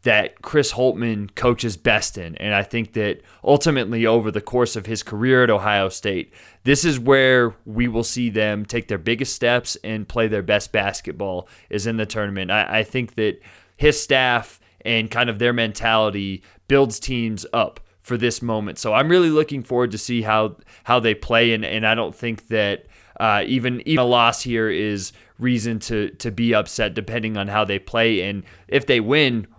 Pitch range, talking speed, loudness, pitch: 105-125 Hz, 195 wpm, -20 LUFS, 115 Hz